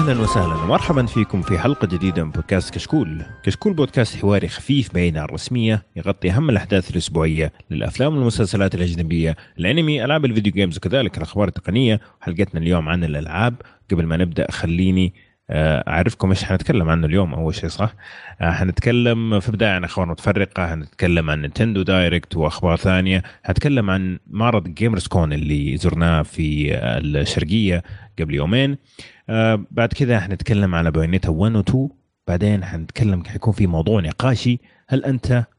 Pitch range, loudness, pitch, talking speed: 85-110 Hz, -20 LUFS, 95 Hz, 140 wpm